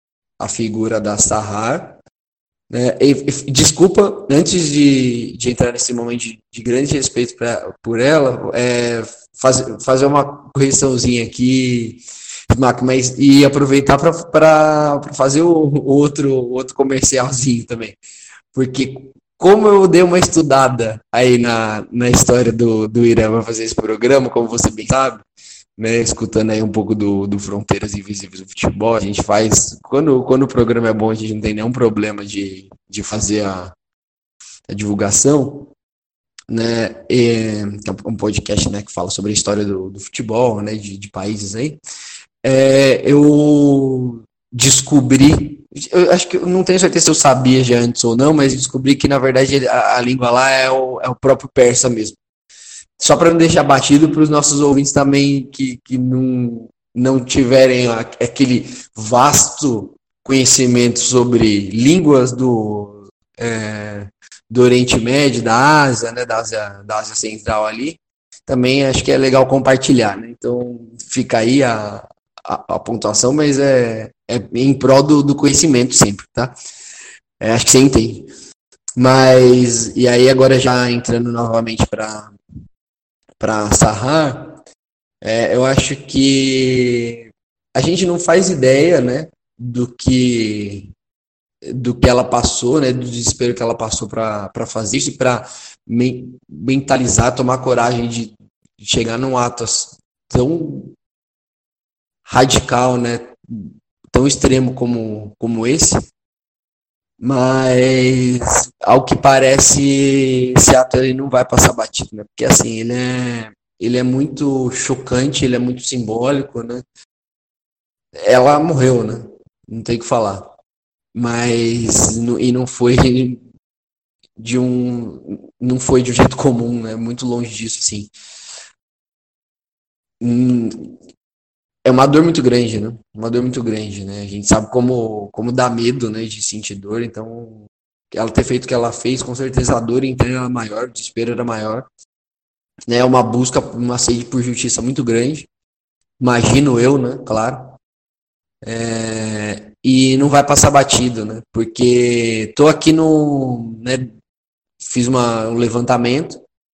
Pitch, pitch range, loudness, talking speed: 125 Hz, 115-135 Hz, -14 LUFS, 145 wpm